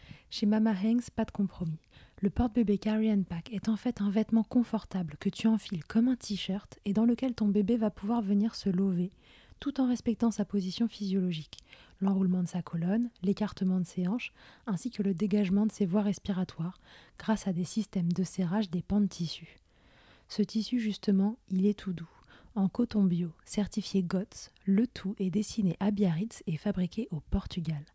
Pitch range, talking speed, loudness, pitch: 185-220 Hz, 185 wpm, -31 LUFS, 200 Hz